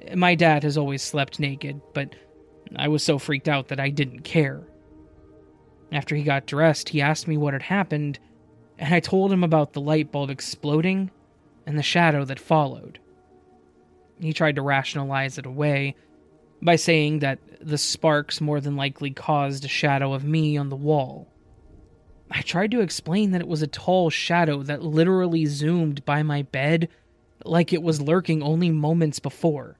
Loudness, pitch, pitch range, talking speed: -23 LUFS, 150 Hz, 135-160 Hz, 170 wpm